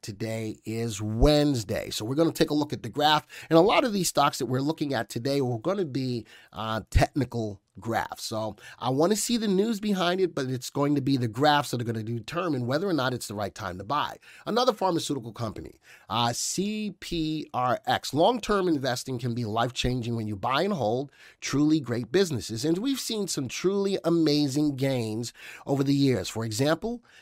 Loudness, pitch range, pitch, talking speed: -27 LUFS, 115-165 Hz, 140 Hz, 205 wpm